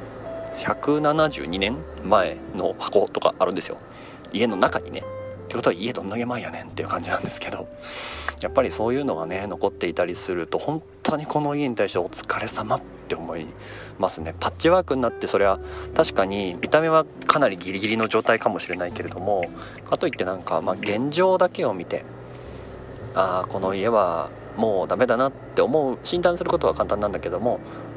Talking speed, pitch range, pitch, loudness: 370 characters per minute, 95-150 Hz, 110 Hz, -24 LUFS